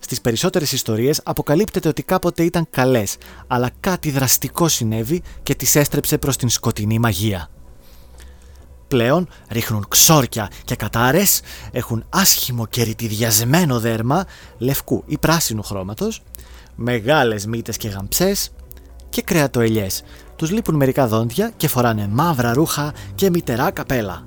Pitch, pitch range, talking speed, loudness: 125 Hz, 110-155 Hz, 125 wpm, -18 LUFS